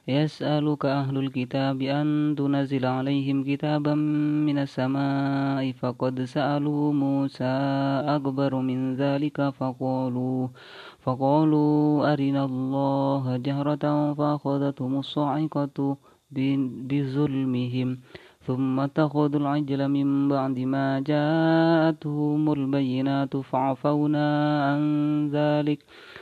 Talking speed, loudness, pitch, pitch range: 80 wpm, -25 LUFS, 140 Hz, 135-150 Hz